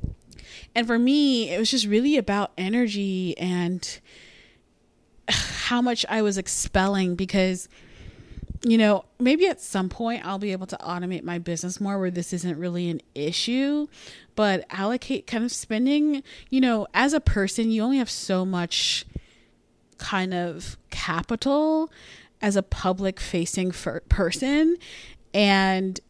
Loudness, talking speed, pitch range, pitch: -24 LUFS, 140 wpm, 185-245 Hz, 200 Hz